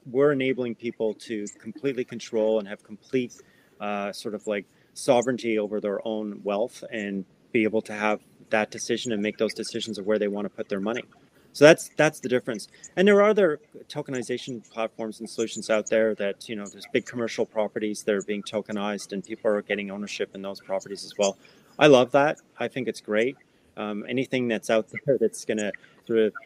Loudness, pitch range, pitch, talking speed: -26 LUFS, 105-125 Hz, 110 Hz, 205 wpm